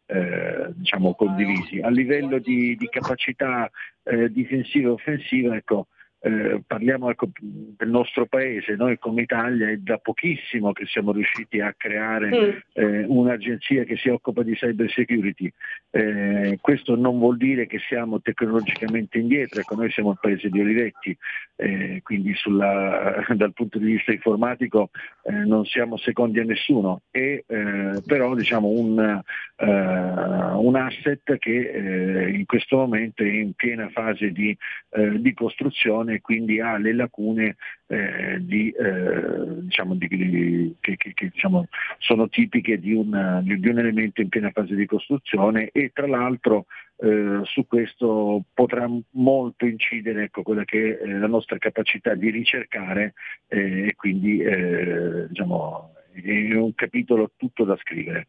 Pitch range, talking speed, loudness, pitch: 105-120 Hz, 135 wpm, -23 LUFS, 110 Hz